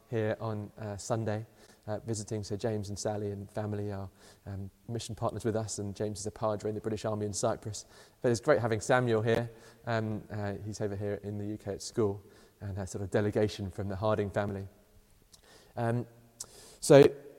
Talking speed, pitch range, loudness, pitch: 200 wpm, 105-110 Hz, -32 LUFS, 105 Hz